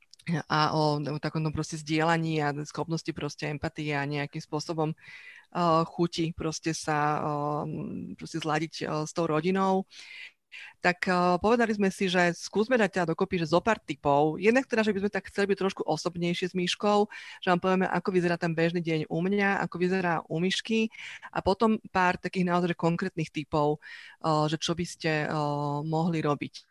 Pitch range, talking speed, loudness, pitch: 155-185 Hz, 175 wpm, -28 LUFS, 170 Hz